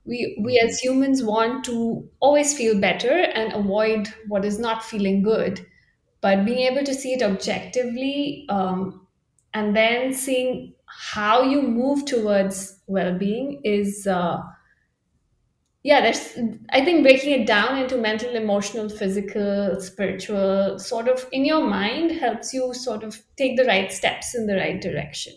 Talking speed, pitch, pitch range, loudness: 150 wpm, 225 Hz, 200-255 Hz, -22 LUFS